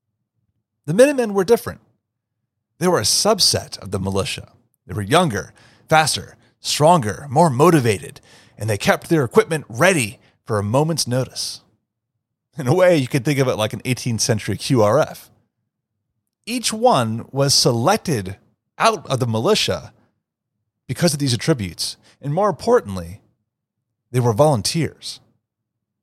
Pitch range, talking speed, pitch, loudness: 110-155 Hz, 135 wpm, 120 Hz, -18 LUFS